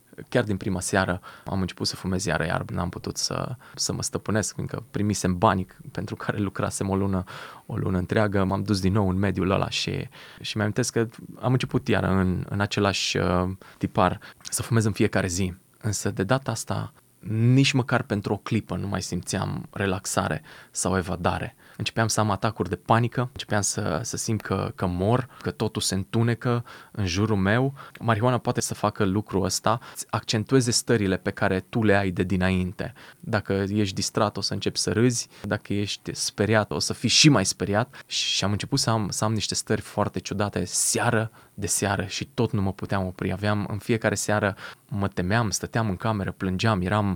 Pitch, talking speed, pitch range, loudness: 105 Hz, 190 wpm, 95-115 Hz, -25 LUFS